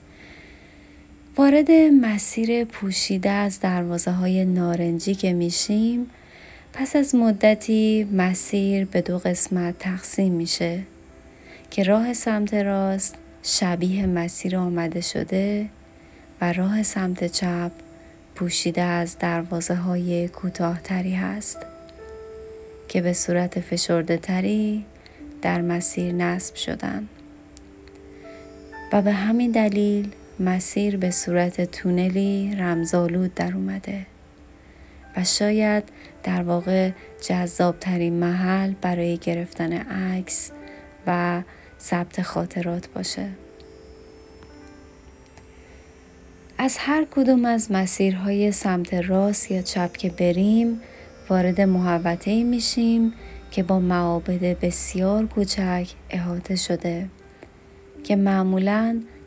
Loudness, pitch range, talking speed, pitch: -22 LUFS, 170-205 Hz, 95 wpm, 180 Hz